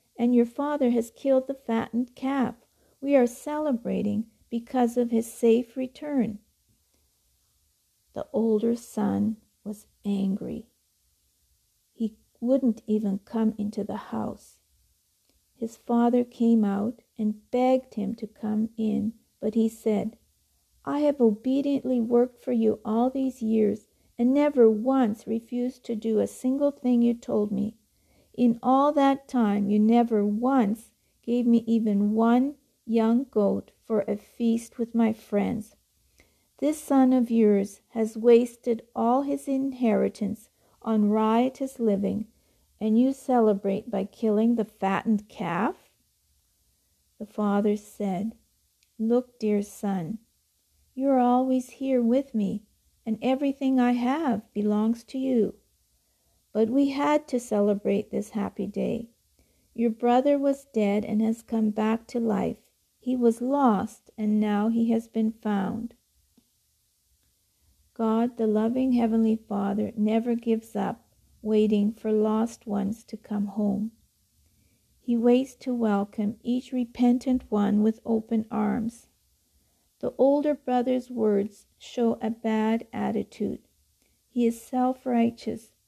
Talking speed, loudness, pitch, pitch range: 130 wpm, -26 LUFS, 230 Hz, 215-250 Hz